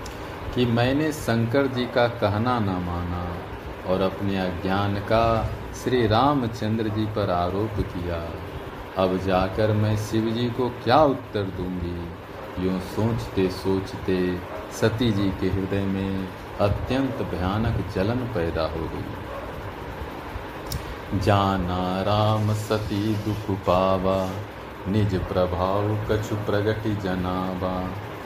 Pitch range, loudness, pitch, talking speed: 95-110 Hz, -25 LUFS, 100 Hz, 105 wpm